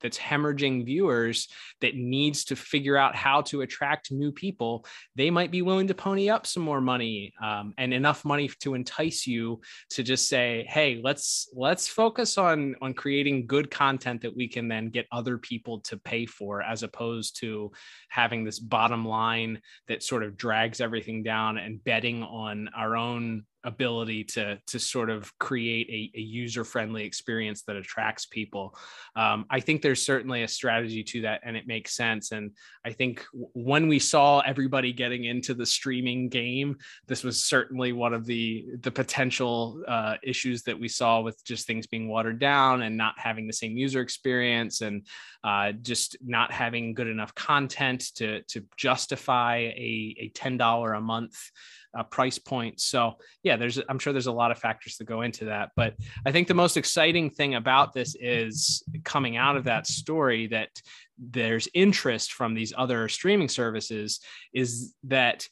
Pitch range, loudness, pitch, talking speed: 115-135 Hz, -27 LUFS, 120 Hz, 180 wpm